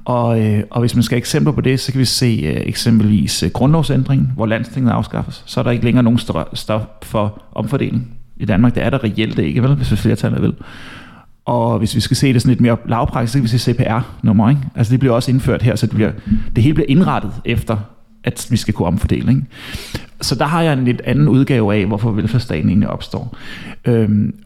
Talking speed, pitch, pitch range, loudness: 230 wpm, 120 Hz, 110-130 Hz, -16 LUFS